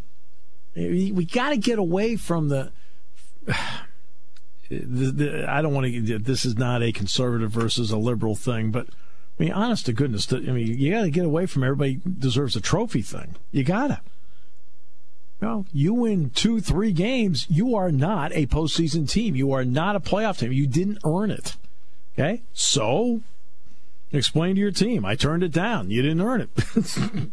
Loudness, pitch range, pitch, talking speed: -24 LUFS, 115-185 Hz, 140 Hz, 180 wpm